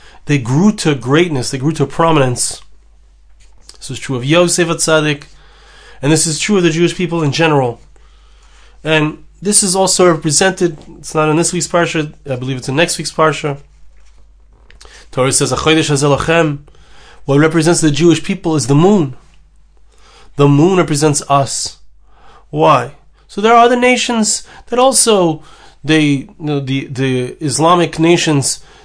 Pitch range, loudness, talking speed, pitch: 140-170 Hz, -13 LUFS, 150 wpm, 155 Hz